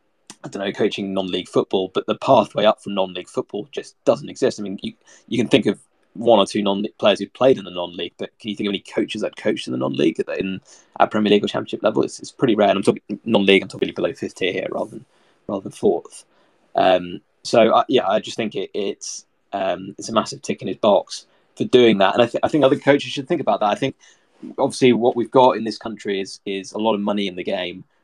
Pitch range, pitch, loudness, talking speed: 95-120 Hz, 105 Hz, -20 LUFS, 260 wpm